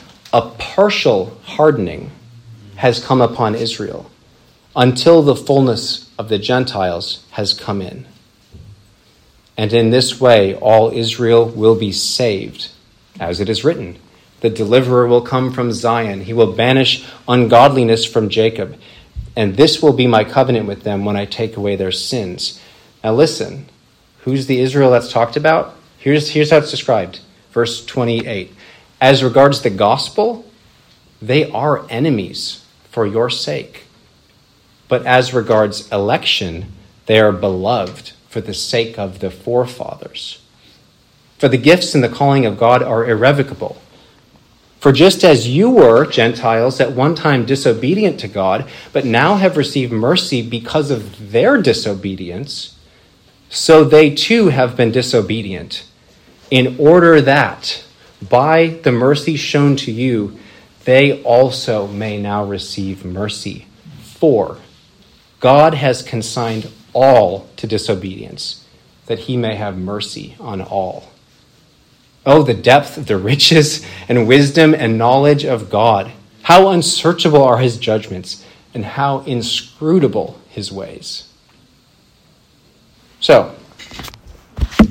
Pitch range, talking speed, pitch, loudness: 105-140 Hz, 130 wpm, 120 Hz, -14 LUFS